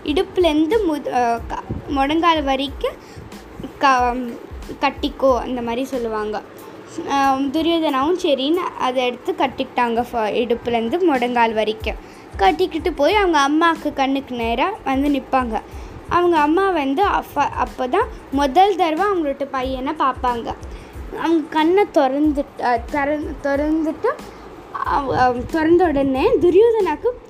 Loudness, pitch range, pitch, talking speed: -19 LUFS, 260-355 Hz, 295 Hz, 95 wpm